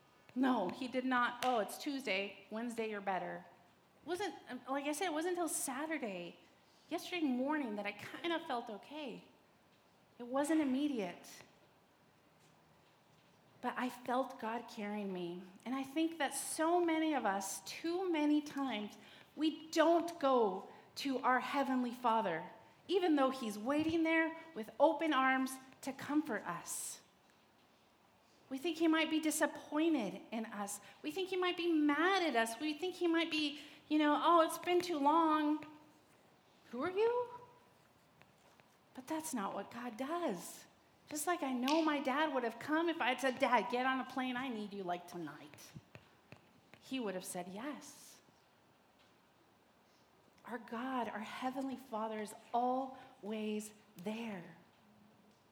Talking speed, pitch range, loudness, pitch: 150 wpm, 225-315 Hz, -37 LUFS, 265 Hz